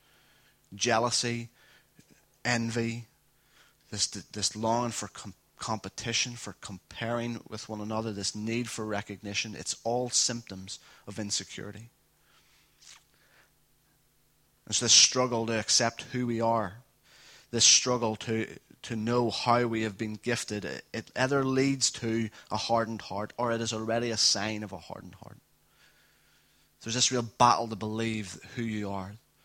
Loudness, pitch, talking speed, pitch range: -28 LUFS, 115 Hz, 130 wpm, 105-120 Hz